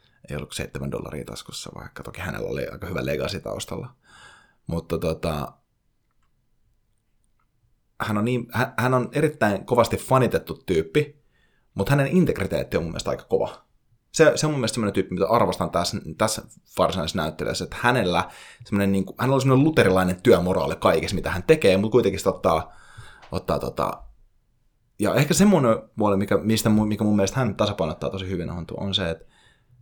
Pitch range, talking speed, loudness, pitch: 95-125 Hz, 165 wpm, -23 LUFS, 110 Hz